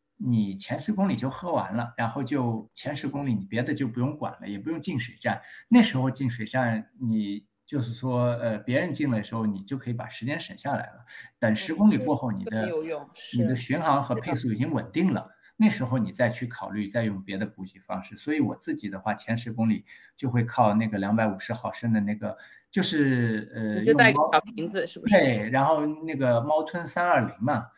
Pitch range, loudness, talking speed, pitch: 110-140 Hz, -27 LUFS, 305 characters per minute, 120 Hz